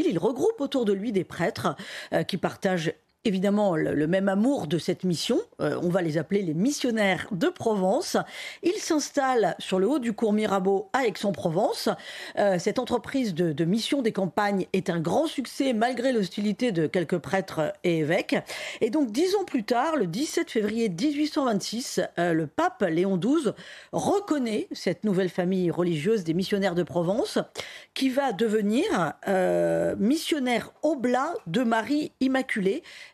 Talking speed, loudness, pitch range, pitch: 160 wpm, -26 LUFS, 185-265 Hz, 210 Hz